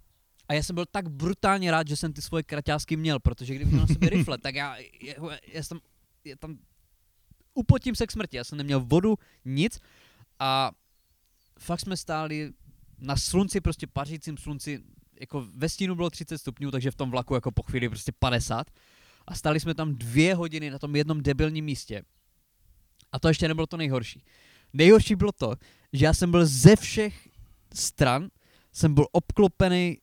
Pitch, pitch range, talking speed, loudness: 150 Hz, 130-165 Hz, 180 wpm, -26 LUFS